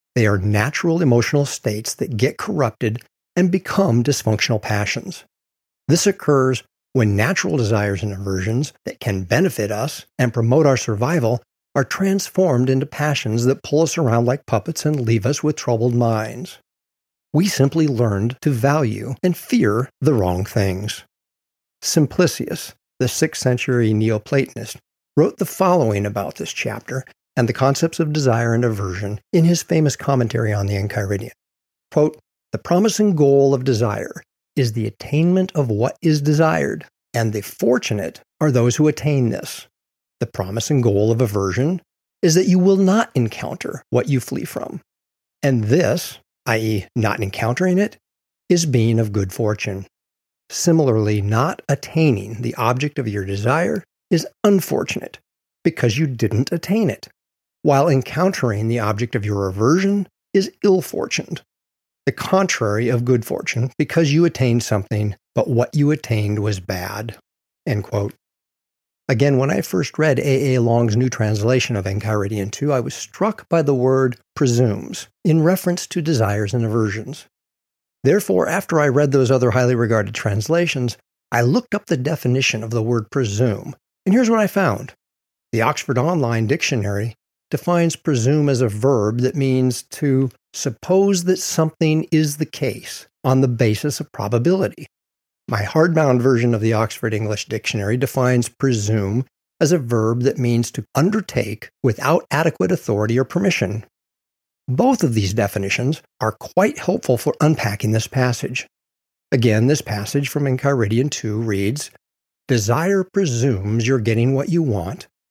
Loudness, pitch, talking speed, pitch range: -19 LUFS, 125 Hz, 150 wpm, 110-155 Hz